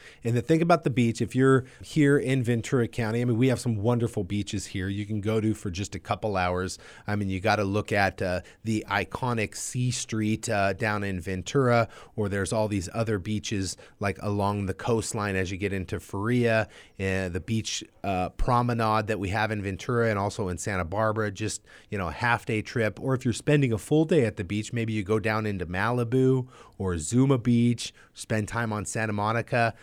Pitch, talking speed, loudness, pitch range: 110 Hz, 215 wpm, -27 LUFS, 100-120 Hz